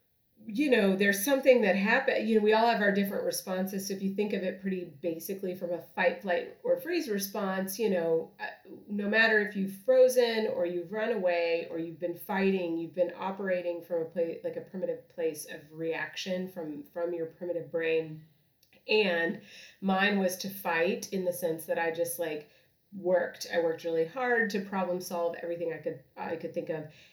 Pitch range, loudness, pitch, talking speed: 170-210 Hz, -30 LUFS, 185 Hz, 195 wpm